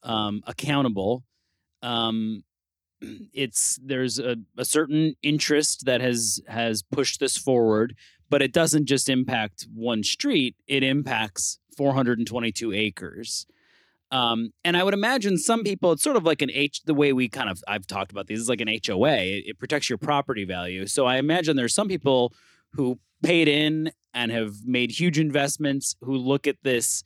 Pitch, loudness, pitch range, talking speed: 125 Hz, -24 LUFS, 110-145 Hz, 170 wpm